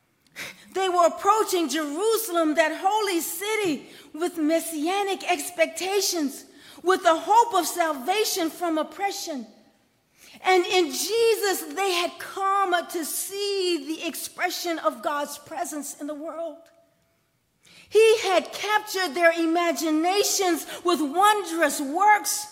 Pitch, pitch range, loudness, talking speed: 350 Hz, 320-390 Hz, -24 LUFS, 110 wpm